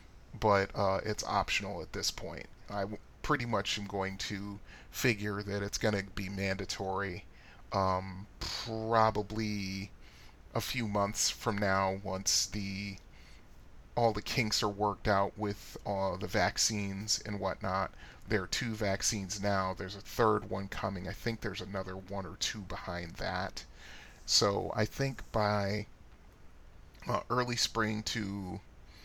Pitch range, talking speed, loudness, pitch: 95-105 Hz, 145 wpm, -34 LUFS, 100 Hz